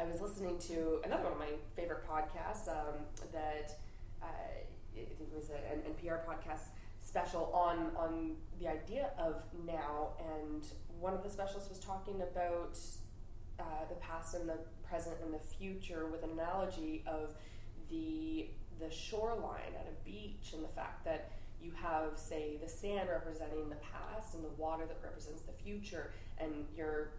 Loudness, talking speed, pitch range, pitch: -43 LUFS, 170 wpm, 150-170 Hz, 160 Hz